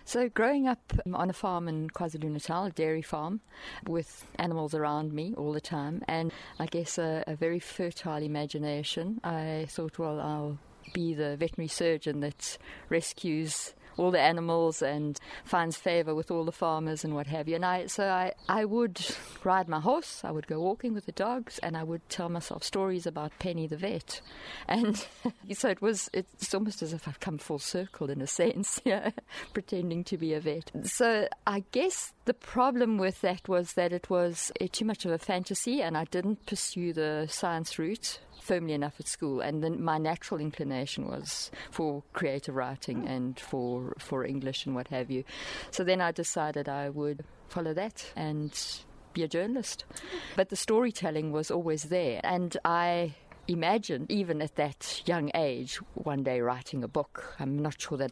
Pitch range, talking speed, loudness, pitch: 150-190 Hz, 185 wpm, -32 LUFS, 165 Hz